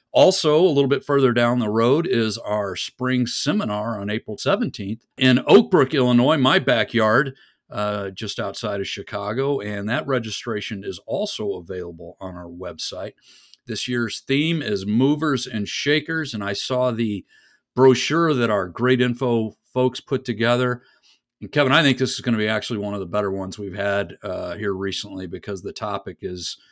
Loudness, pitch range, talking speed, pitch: -21 LUFS, 100-130 Hz, 175 wpm, 115 Hz